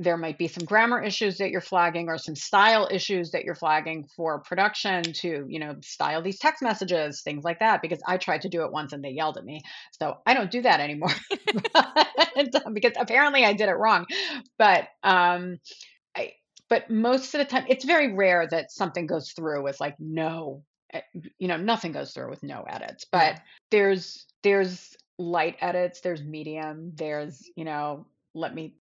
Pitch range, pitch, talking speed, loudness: 160-220 Hz, 180 Hz, 185 wpm, -25 LUFS